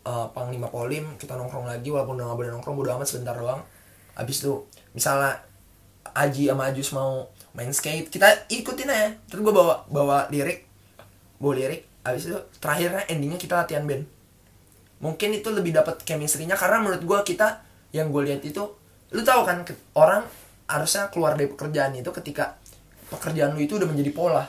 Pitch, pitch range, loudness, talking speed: 145 Hz, 125-175 Hz, -25 LUFS, 170 wpm